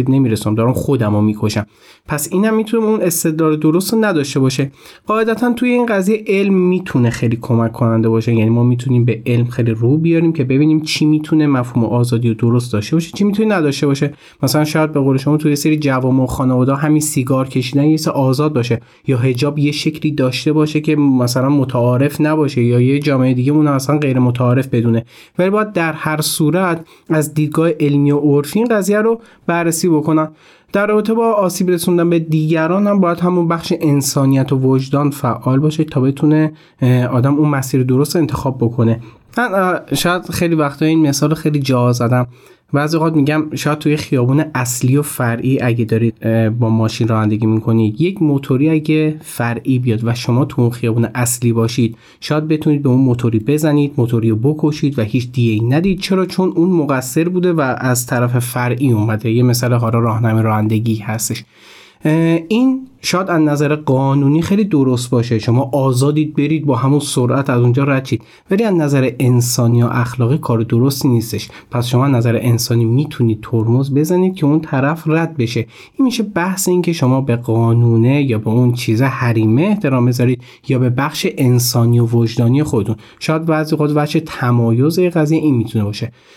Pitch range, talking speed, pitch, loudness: 120-155 Hz, 180 wpm, 140 Hz, -15 LUFS